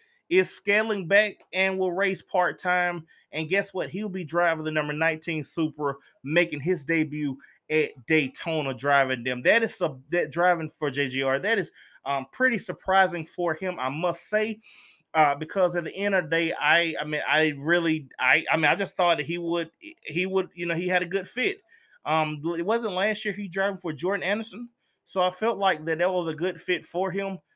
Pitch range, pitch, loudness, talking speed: 155-195 Hz, 175 Hz, -25 LUFS, 205 wpm